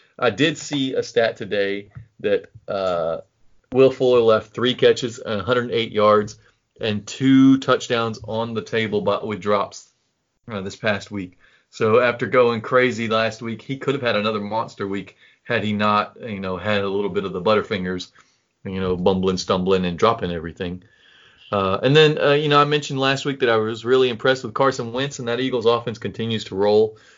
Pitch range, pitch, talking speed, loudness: 100-130 Hz, 115 Hz, 190 wpm, -20 LUFS